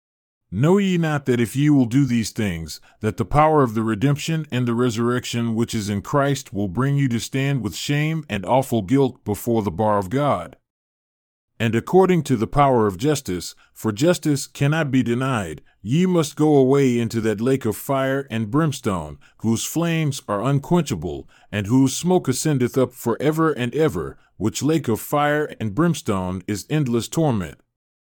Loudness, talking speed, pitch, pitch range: -21 LUFS, 175 wpm, 130 Hz, 110-145 Hz